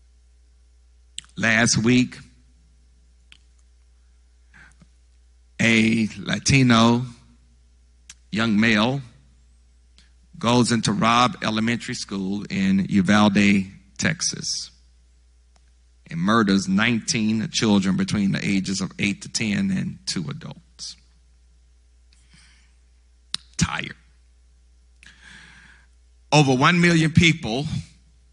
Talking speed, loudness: 70 wpm, -20 LUFS